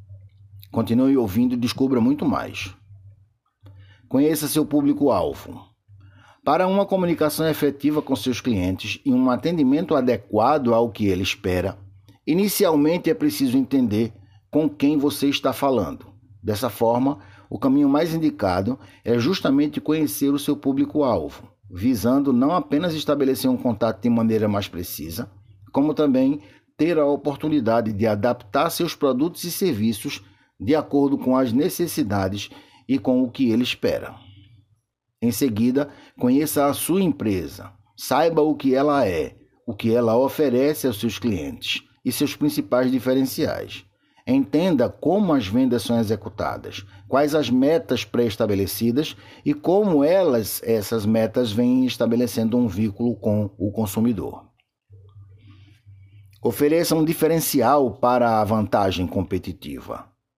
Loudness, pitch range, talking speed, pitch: -21 LUFS, 105-145 Hz, 125 wpm, 125 Hz